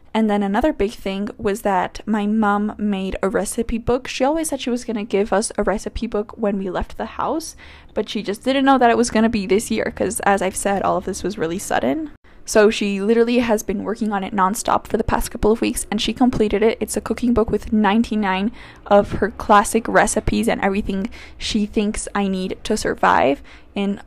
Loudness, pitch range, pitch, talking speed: -20 LUFS, 200-230 Hz, 210 Hz, 225 wpm